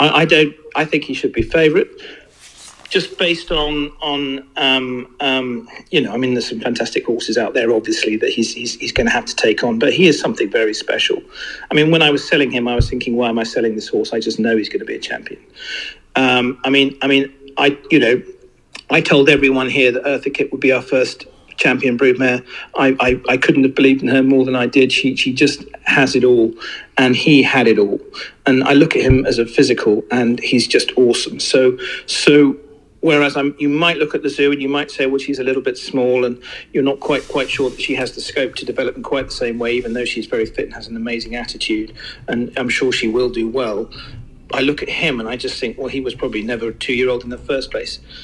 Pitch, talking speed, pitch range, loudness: 130 Hz, 245 wpm, 125-145 Hz, -16 LUFS